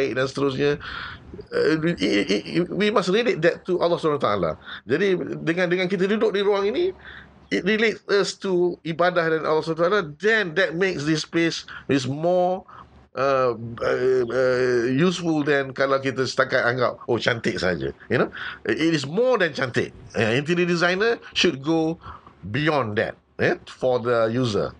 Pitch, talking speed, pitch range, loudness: 165 Hz, 160 wpm, 135-185 Hz, -22 LUFS